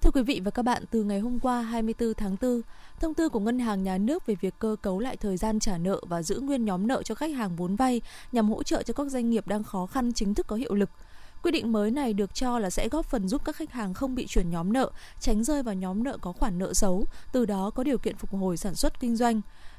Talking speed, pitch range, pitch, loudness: 280 wpm, 200-255 Hz, 225 Hz, -29 LUFS